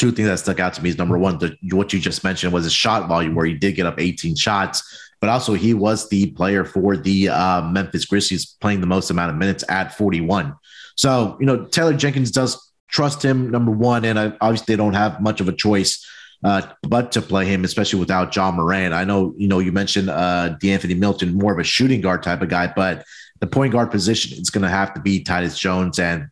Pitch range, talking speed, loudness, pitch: 90-110 Hz, 240 wpm, -19 LUFS, 95 Hz